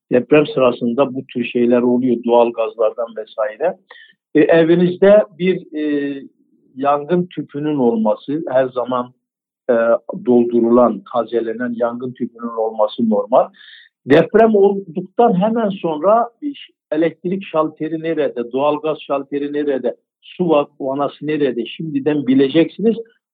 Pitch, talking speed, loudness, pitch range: 145 Hz, 105 wpm, -17 LUFS, 125-180 Hz